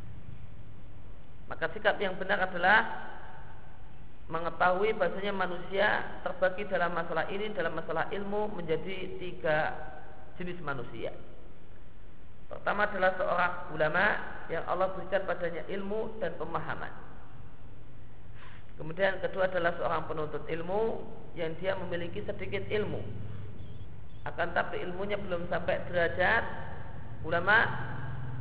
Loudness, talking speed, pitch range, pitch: -32 LUFS, 100 wpm, 125-185 Hz, 170 Hz